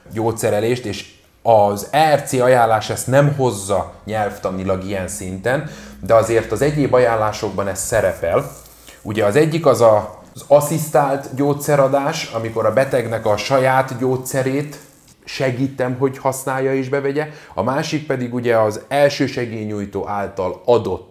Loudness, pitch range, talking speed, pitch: -18 LUFS, 105-140 Hz, 130 wpm, 125 Hz